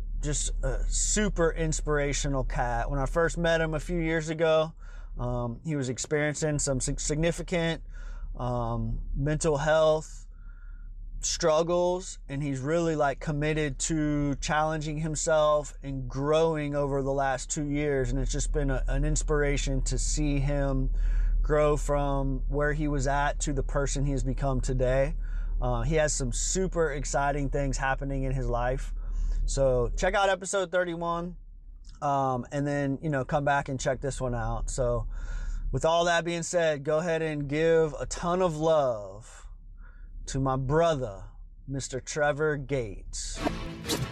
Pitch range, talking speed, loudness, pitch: 130-155 Hz, 150 wpm, -28 LUFS, 140 Hz